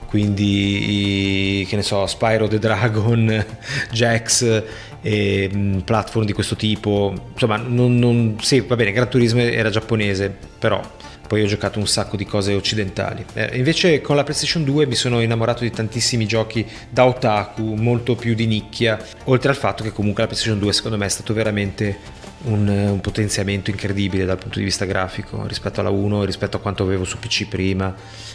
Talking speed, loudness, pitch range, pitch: 180 wpm, -19 LUFS, 100-115 Hz, 110 Hz